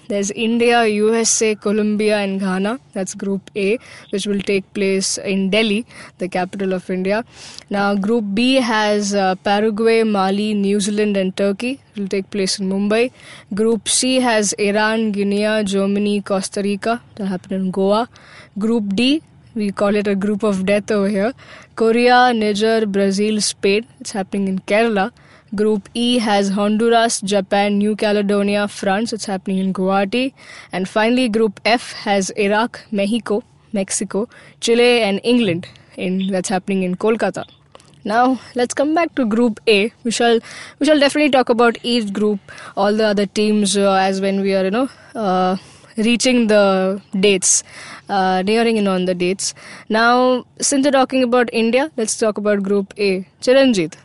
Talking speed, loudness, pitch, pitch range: 160 wpm, -17 LUFS, 210 Hz, 195-230 Hz